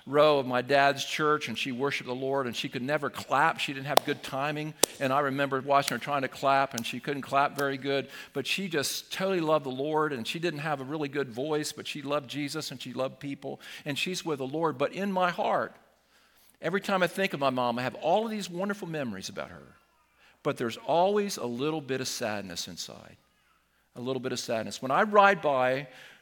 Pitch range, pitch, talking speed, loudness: 130-155 Hz, 140 Hz, 230 wpm, -29 LUFS